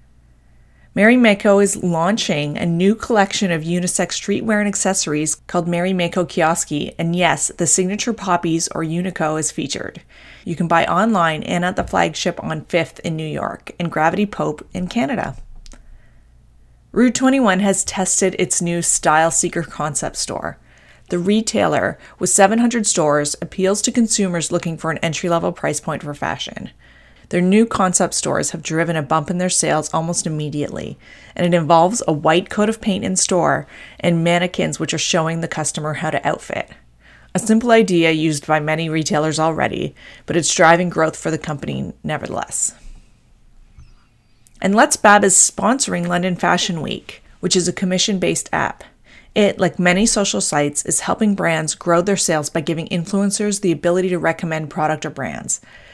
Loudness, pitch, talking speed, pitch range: -18 LUFS, 175 Hz, 165 wpm, 160-195 Hz